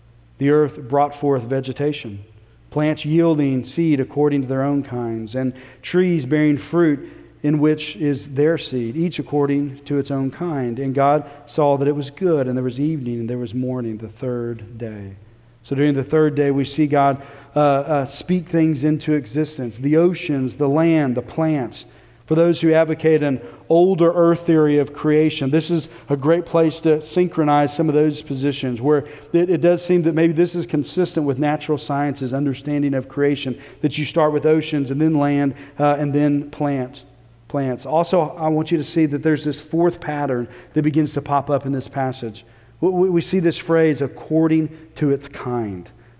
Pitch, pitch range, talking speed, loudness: 145 Hz, 135-155 Hz, 185 wpm, -19 LUFS